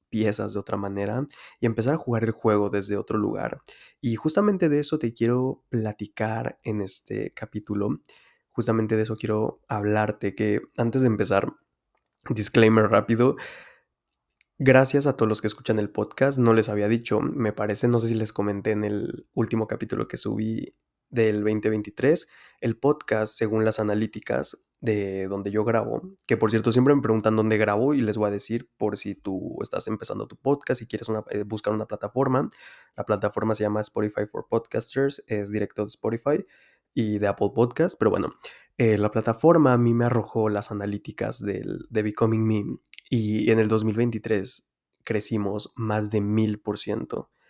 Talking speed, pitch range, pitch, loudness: 170 wpm, 105-115 Hz, 110 Hz, -25 LUFS